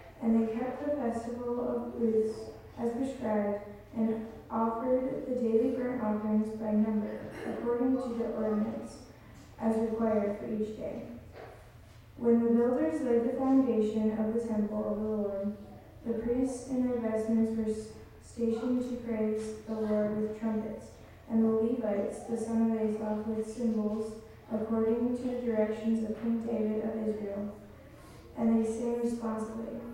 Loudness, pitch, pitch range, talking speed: -32 LUFS, 225 Hz, 215-235 Hz, 145 wpm